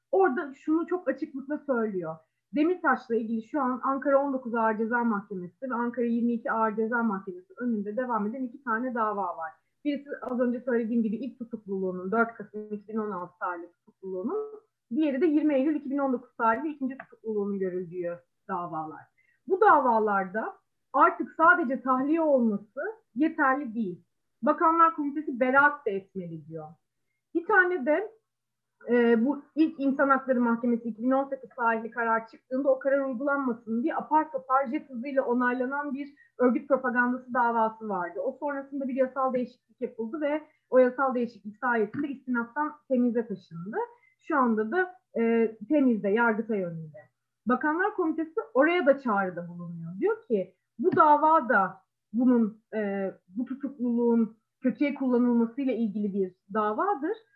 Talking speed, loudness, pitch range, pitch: 135 wpm, -27 LUFS, 220-285 Hz, 250 Hz